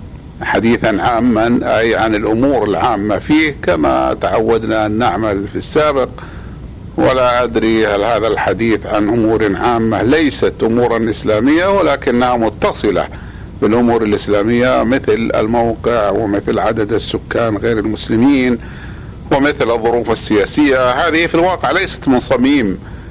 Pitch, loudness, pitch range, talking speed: 115 Hz, -14 LUFS, 110-125 Hz, 115 wpm